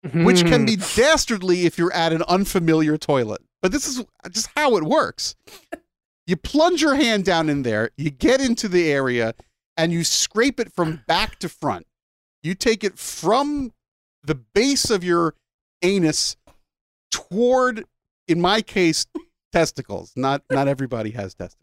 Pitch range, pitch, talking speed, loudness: 155-230 Hz, 175 Hz, 155 wpm, -20 LUFS